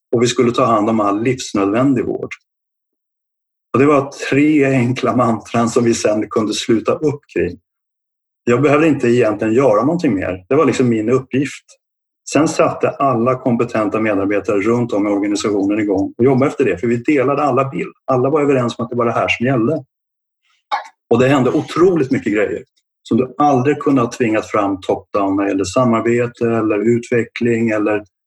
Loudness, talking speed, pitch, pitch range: -16 LUFS, 175 wpm, 120 Hz, 110-130 Hz